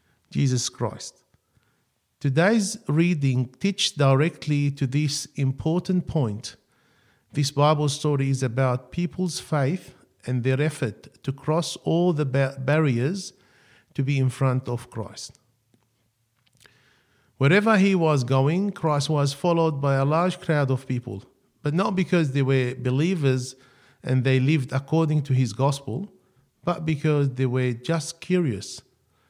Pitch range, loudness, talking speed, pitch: 130-160 Hz, -24 LUFS, 130 wpm, 140 Hz